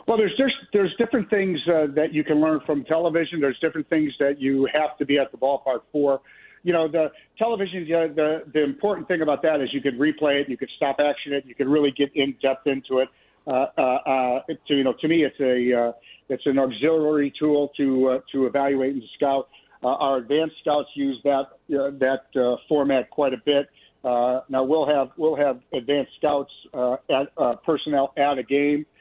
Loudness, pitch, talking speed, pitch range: -23 LUFS, 145 Hz, 215 wpm, 135-155 Hz